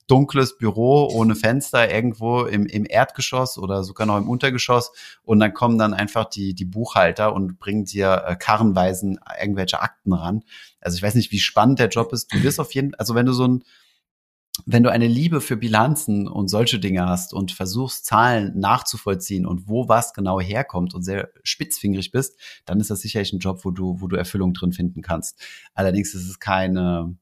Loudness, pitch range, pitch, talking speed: -21 LUFS, 95-120 Hz, 105 Hz, 190 wpm